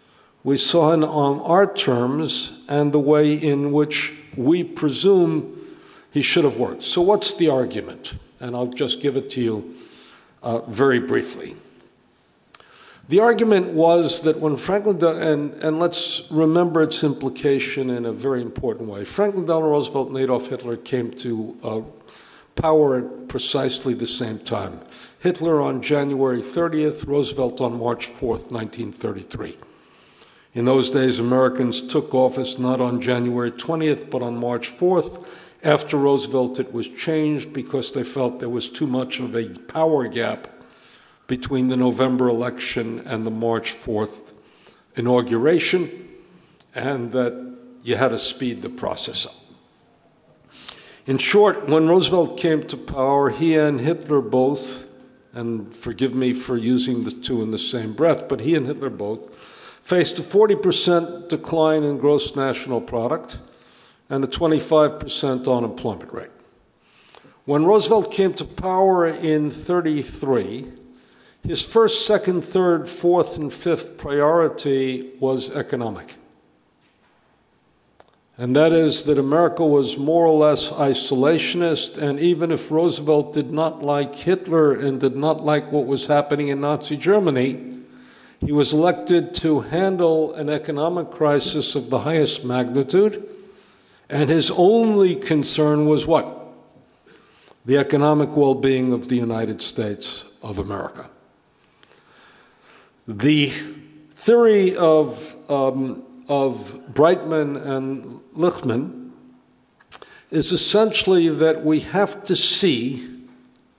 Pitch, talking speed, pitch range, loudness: 145 Hz, 135 wpm, 125-160 Hz, -20 LUFS